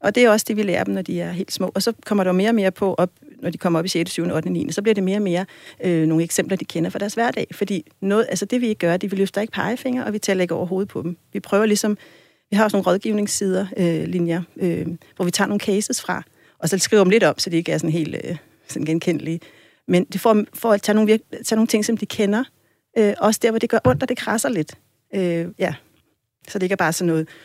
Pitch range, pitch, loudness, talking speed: 170-215 Hz, 195 Hz, -21 LUFS, 290 wpm